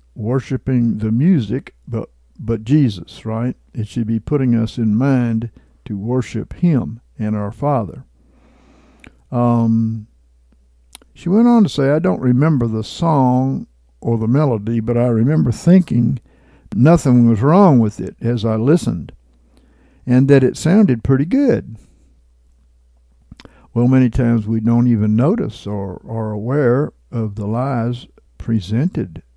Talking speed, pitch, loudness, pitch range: 135 wpm, 115 Hz, -16 LUFS, 110-130 Hz